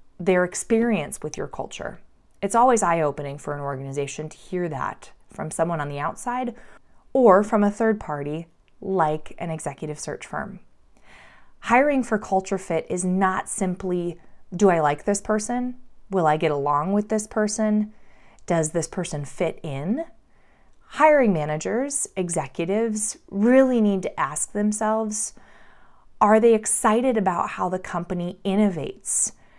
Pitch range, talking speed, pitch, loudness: 160-215 Hz, 140 wpm, 190 Hz, -23 LUFS